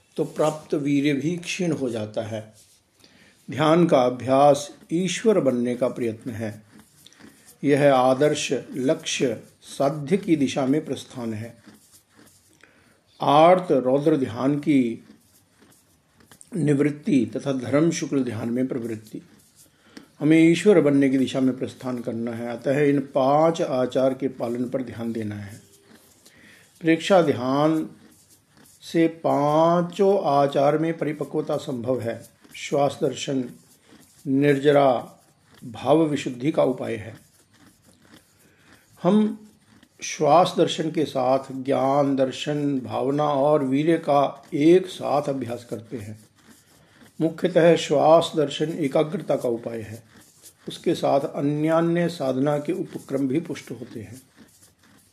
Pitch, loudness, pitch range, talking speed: 140 Hz, -22 LUFS, 125-155 Hz, 115 wpm